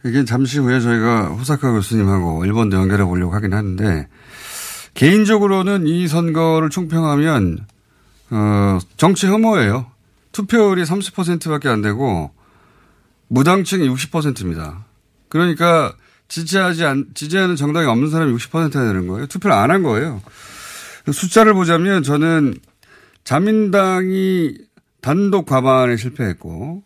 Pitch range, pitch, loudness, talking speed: 105-175 Hz, 145 Hz, -16 LUFS, 275 characters per minute